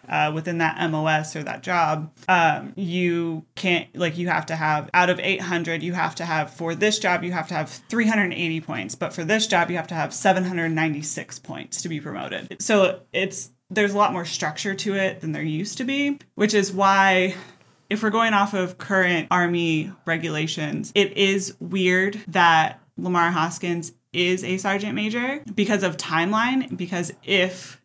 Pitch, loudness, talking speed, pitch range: 180 Hz, -22 LUFS, 180 wpm, 160-195 Hz